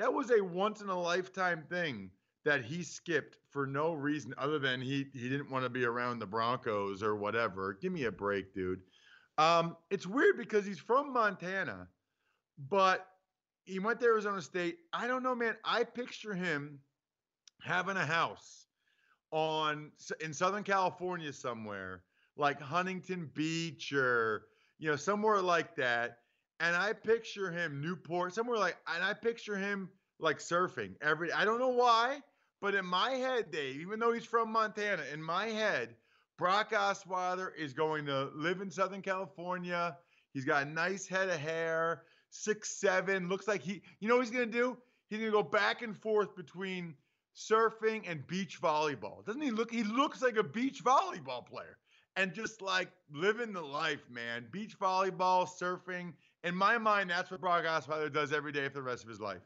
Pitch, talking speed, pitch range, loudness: 180 Hz, 175 wpm, 150-205 Hz, -34 LUFS